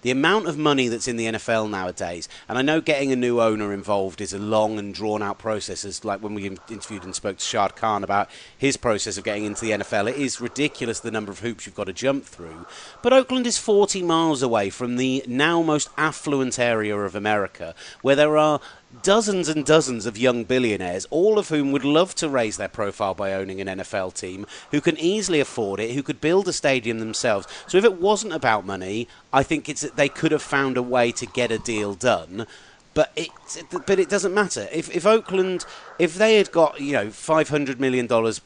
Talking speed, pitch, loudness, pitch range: 220 wpm, 130 Hz, -22 LUFS, 105-155 Hz